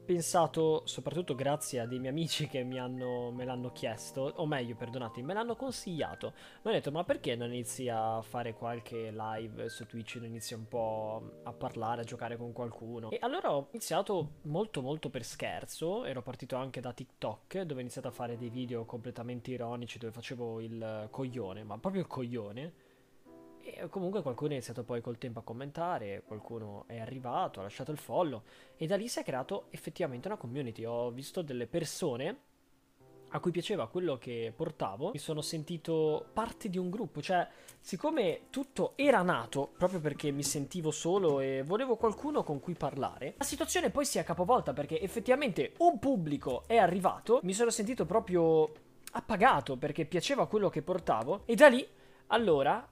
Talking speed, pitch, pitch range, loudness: 180 wpm, 140 Hz, 120-180 Hz, -34 LUFS